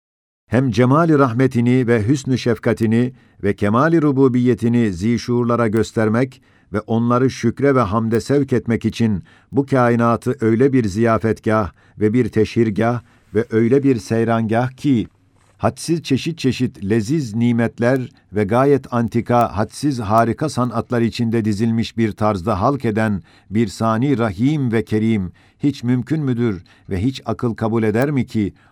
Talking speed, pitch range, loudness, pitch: 135 wpm, 110-125 Hz, -18 LUFS, 115 Hz